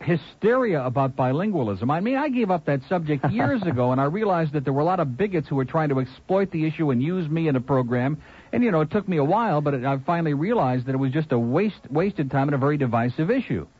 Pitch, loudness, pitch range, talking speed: 150 Hz, -23 LUFS, 135-175 Hz, 260 wpm